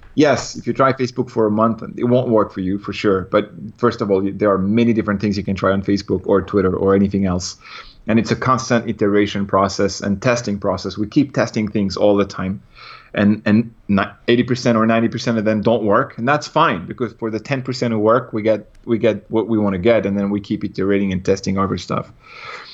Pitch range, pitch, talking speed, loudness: 100-115 Hz, 105 Hz, 225 wpm, -18 LUFS